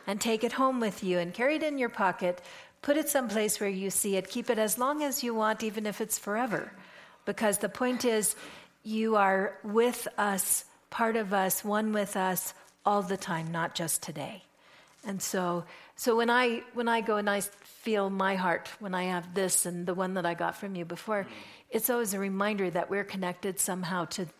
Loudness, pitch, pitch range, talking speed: -30 LUFS, 205 Hz, 190-230 Hz, 210 wpm